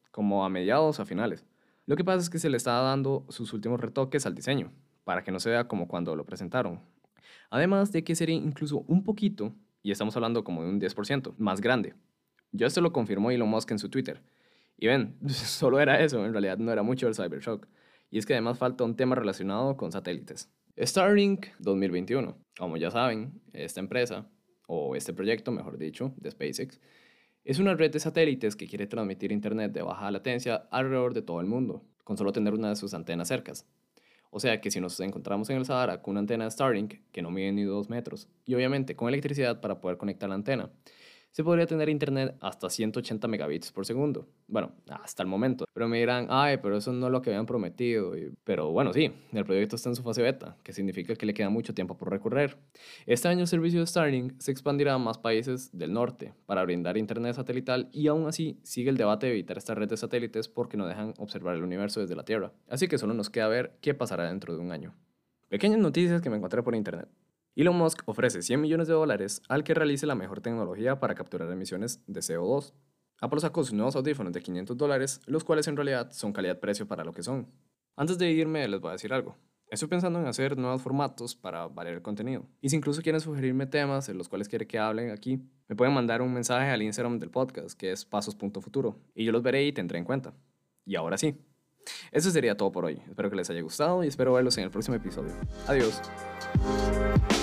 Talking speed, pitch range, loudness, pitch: 220 wpm, 105-145 Hz, -30 LUFS, 125 Hz